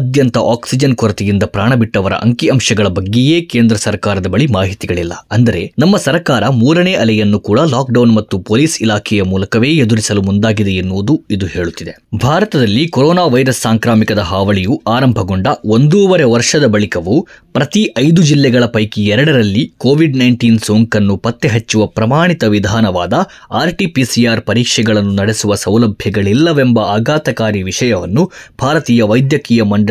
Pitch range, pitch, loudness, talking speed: 105-130 Hz, 115 Hz, -12 LUFS, 115 wpm